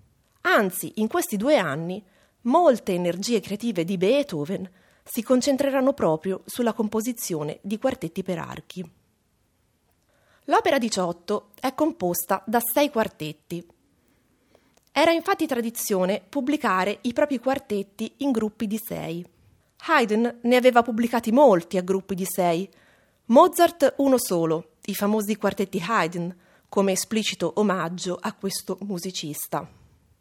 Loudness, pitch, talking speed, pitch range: -24 LUFS, 205 Hz, 115 wpm, 180-240 Hz